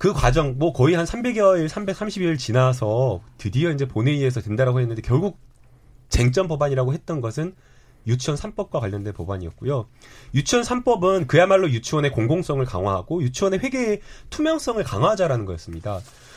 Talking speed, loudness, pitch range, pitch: 365 characters per minute, -22 LUFS, 120-180 Hz, 135 Hz